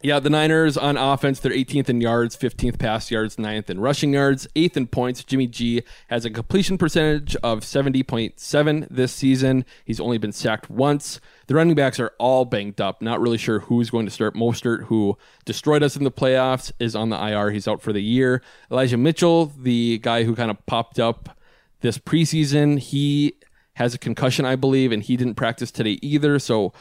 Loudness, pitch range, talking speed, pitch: -21 LUFS, 115-145 Hz, 195 wpm, 125 Hz